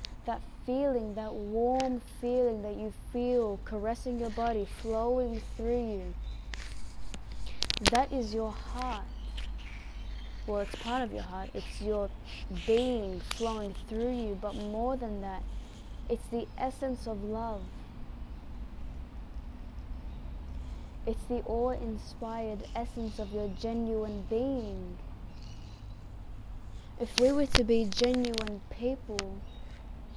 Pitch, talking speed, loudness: 220 Hz, 110 wpm, -34 LUFS